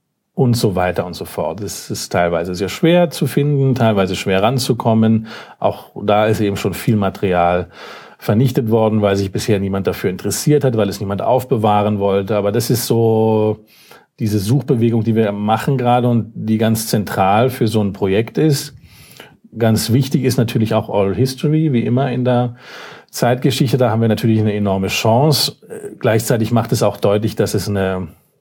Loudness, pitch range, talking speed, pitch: -16 LUFS, 100-130 Hz, 175 wpm, 110 Hz